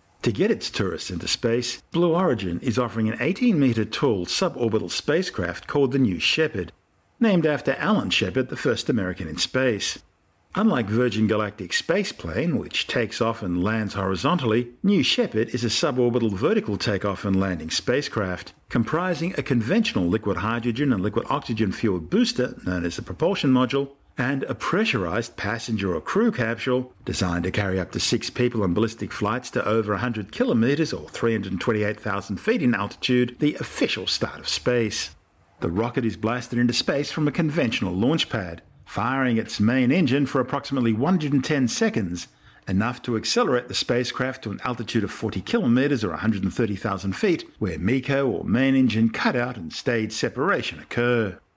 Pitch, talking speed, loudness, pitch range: 120 Hz, 160 wpm, -24 LUFS, 105-130 Hz